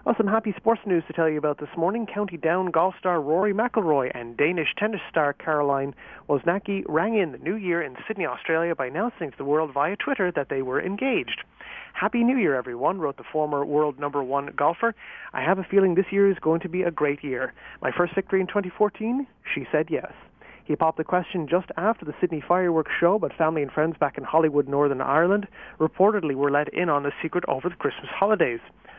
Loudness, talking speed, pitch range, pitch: -25 LUFS, 215 wpm, 150-195 Hz, 170 Hz